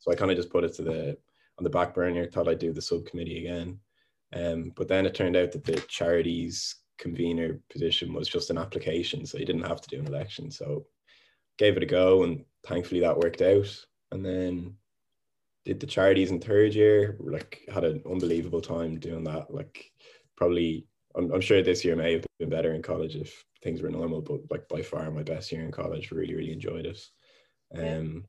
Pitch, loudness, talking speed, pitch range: 85 Hz, -28 LUFS, 210 wpm, 85-95 Hz